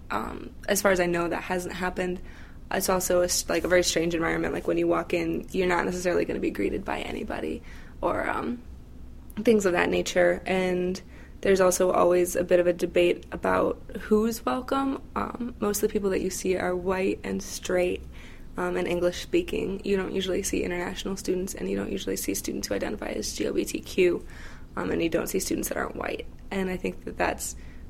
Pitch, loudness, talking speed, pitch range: 180 Hz, -27 LUFS, 200 wpm, 170-195 Hz